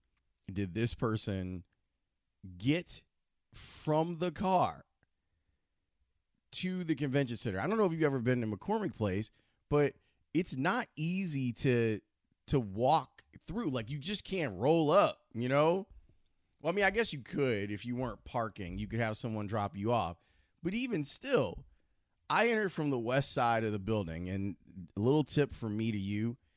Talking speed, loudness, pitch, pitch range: 170 wpm, -33 LUFS, 120 Hz, 100-150 Hz